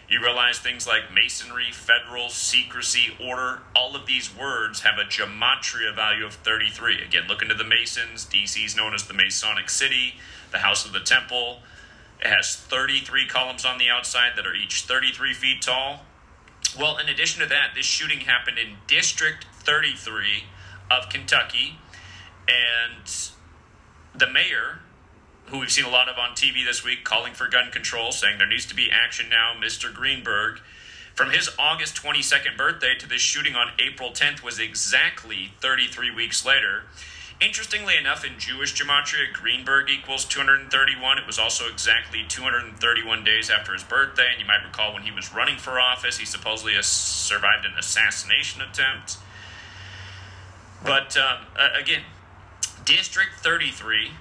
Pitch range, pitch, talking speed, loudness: 100-130 Hz, 120 Hz, 155 wpm, -21 LUFS